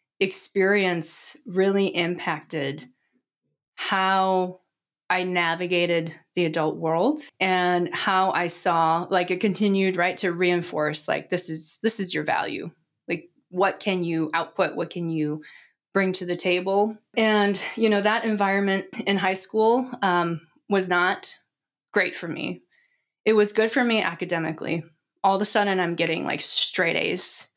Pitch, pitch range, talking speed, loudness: 185 Hz, 170-200 Hz, 145 wpm, -24 LUFS